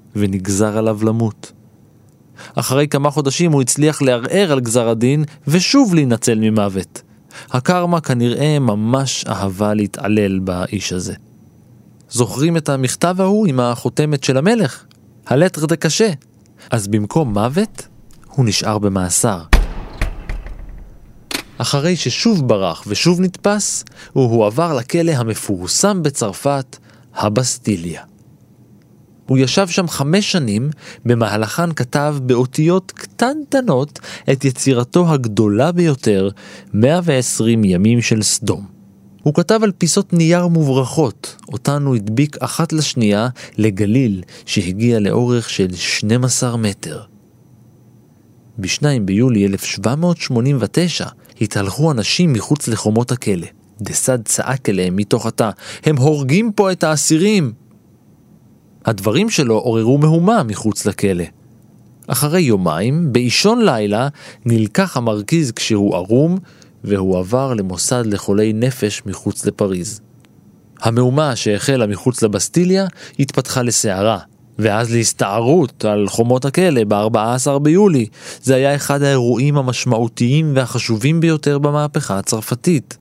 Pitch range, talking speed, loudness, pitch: 110-150 Hz, 105 wpm, -16 LUFS, 125 Hz